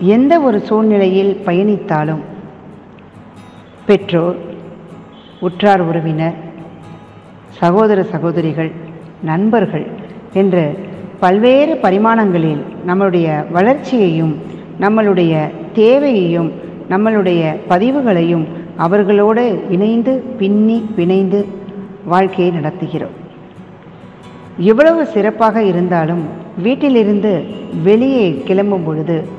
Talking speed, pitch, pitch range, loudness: 65 wpm, 190 Hz, 170-215 Hz, -13 LUFS